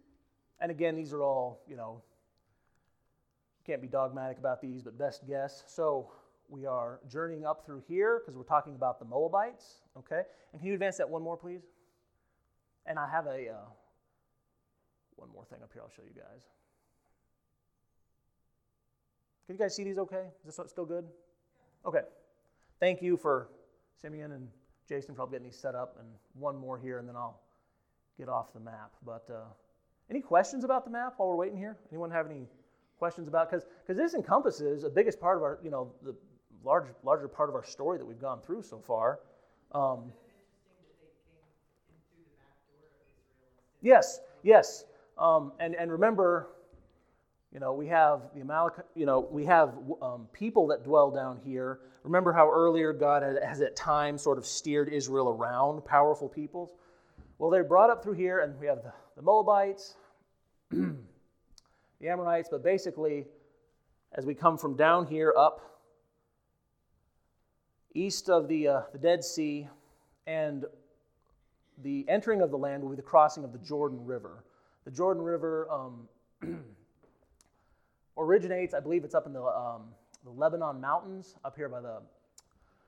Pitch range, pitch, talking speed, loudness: 135-175 Hz, 155 Hz, 165 wpm, -30 LUFS